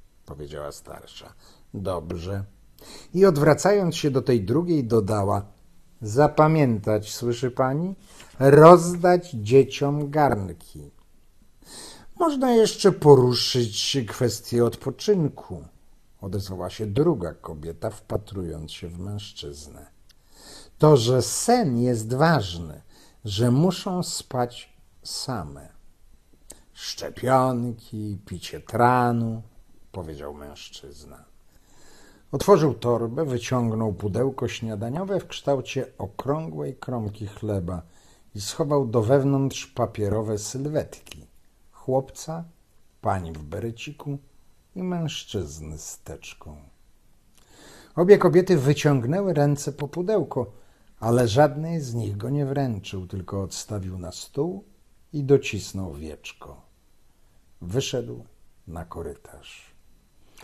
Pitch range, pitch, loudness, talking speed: 95-145 Hz, 120 Hz, -23 LUFS, 90 wpm